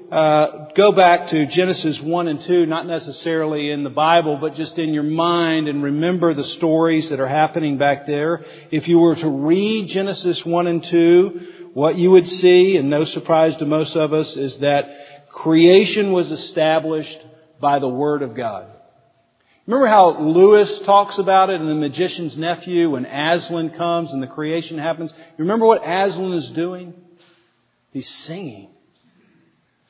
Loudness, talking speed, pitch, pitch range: -17 LUFS, 165 wpm, 160 Hz, 150-175 Hz